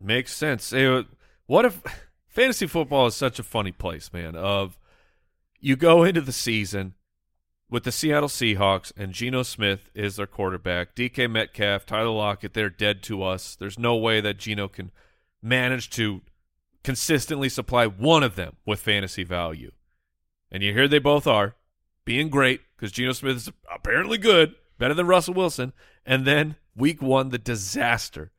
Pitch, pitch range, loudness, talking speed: 110 Hz, 95-130 Hz, -23 LUFS, 160 wpm